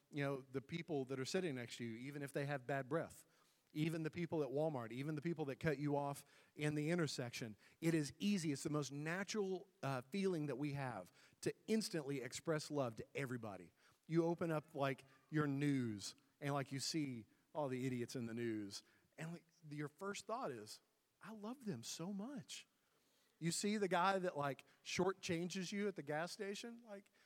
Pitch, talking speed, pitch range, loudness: 150 Hz, 200 wpm, 135-175 Hz, -44 LUFS